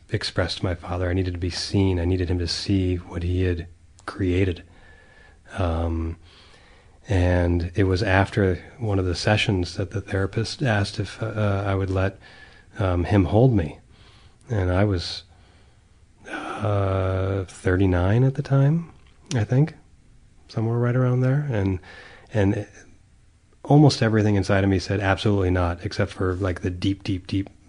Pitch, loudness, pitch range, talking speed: 95 Hz, -23 LUFS, 90-105 Hz, 155 wpm